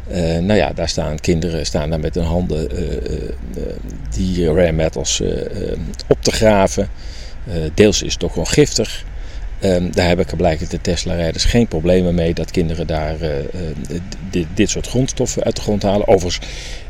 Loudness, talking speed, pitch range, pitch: -18 LUFS, 180 wpm, 80-95 Hz, 85 Hz